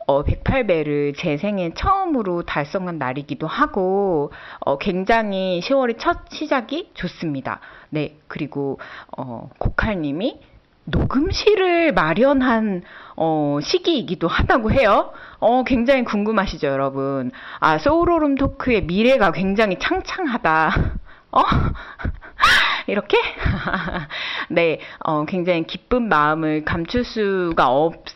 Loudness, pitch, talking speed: -20 LUFS, 190 Hz, 240 characters per minute